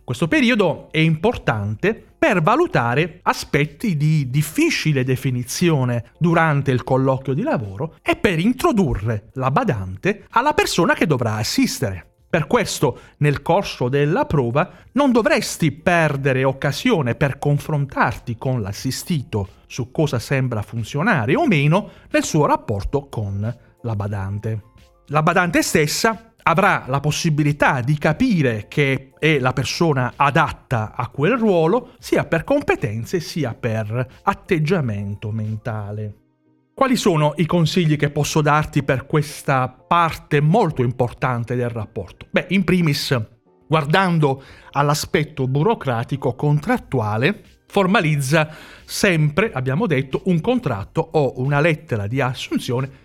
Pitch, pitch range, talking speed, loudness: 145 Hz, 125-170 Hz, 120 wpm, -19 LUFS